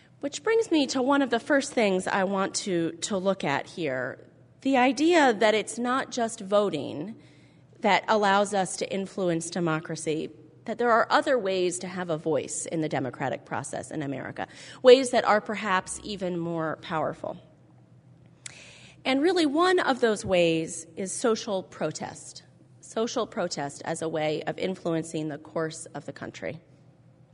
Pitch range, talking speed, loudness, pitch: 165-240 Hz, 160 wpm, -26 LUFS, 195 Hz